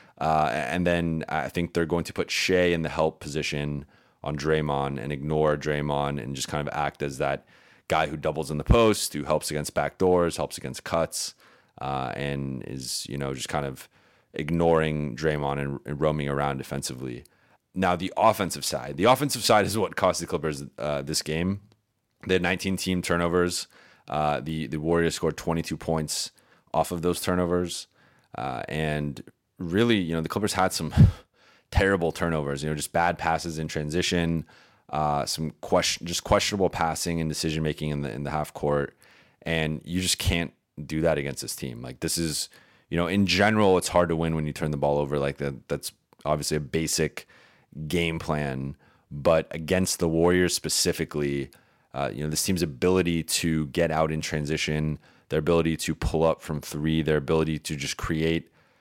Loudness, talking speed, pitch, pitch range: -26 LUFS, 185 wpm, 80 Hz, 75-85 Hz